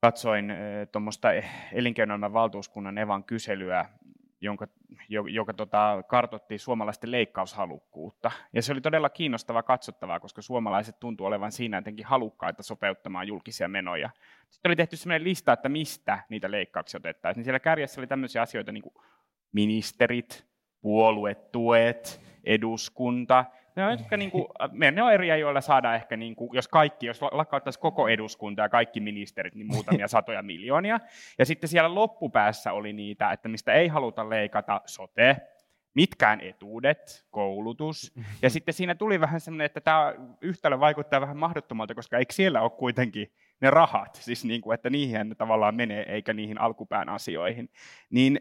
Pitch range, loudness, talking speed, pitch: 110-145 Hz, -27 LUFS, 145 wpm, 120 Hz